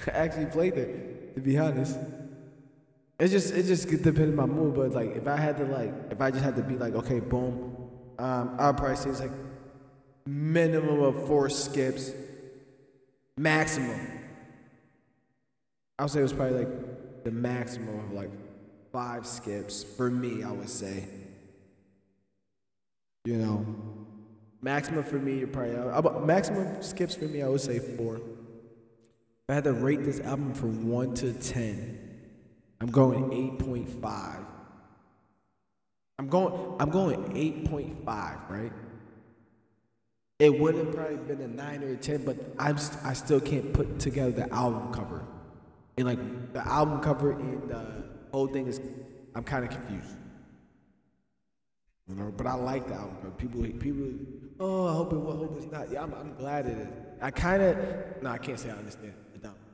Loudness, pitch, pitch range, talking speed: -30 LUFS, 130 Hz, 115-145 Hz, 165 wpm